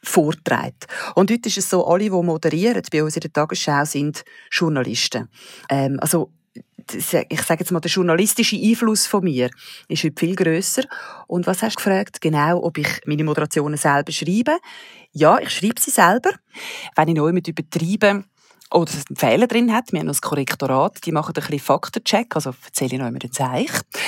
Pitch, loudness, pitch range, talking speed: 170 Hz, -19 LUFS, 150-205 Hz, 170 wpm